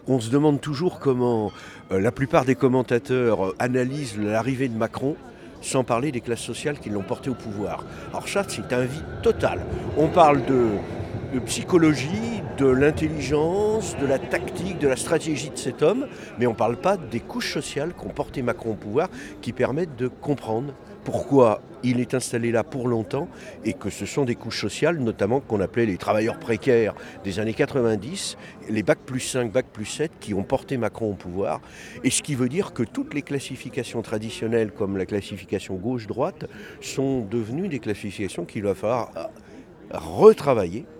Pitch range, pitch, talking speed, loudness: 110-145 Hz, 125 Hz, 175 wpm, -24 LUFS